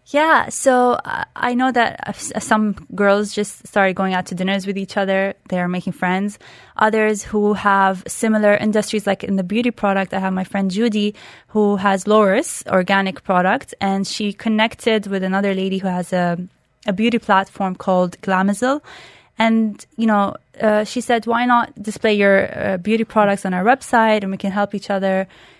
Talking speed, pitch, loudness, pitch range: 180 wpm, 205 Hz, -18 LUFS, 195-220 Hz